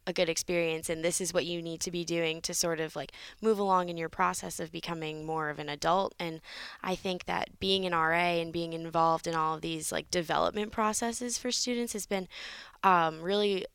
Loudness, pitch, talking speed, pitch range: -31 LUFS, 170 Hz, 220 wpm, 165-190 Hz